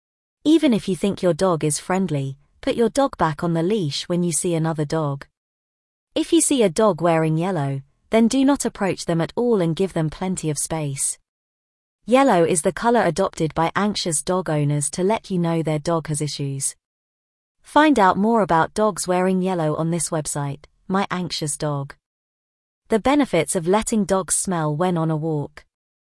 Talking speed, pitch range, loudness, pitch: 185 wpm, 155-200 Hz, -21 LUFS, 170 Hz